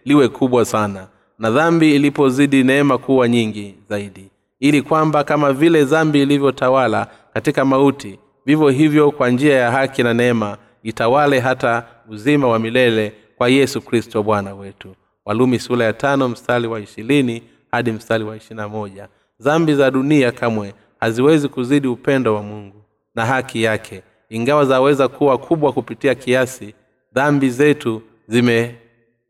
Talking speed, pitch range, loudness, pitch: 130 wpm, 110-140 Hz, -16 LUFS, 120 Hz